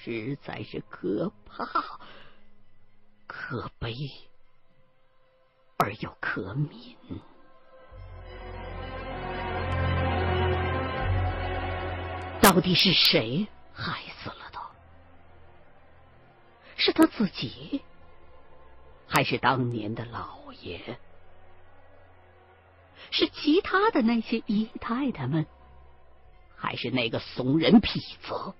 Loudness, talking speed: -27 LUFS, 100 characters per minute